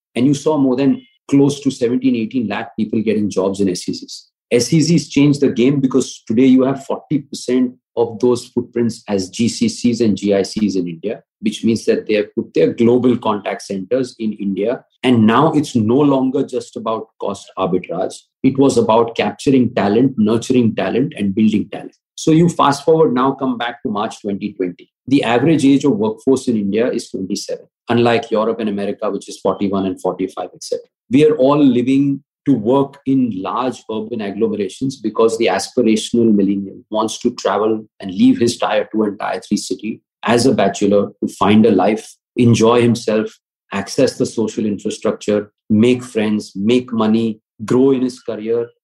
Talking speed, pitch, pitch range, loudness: 170 wpm, 120 Hz, 110-135 Hz, -16 LUFS